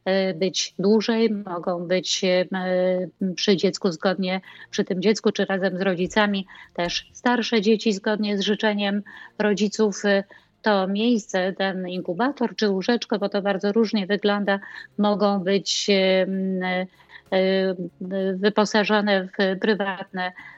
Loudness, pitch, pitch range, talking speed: -23 LUFS, 195 Hz, 190-210 Hz, 110 wpm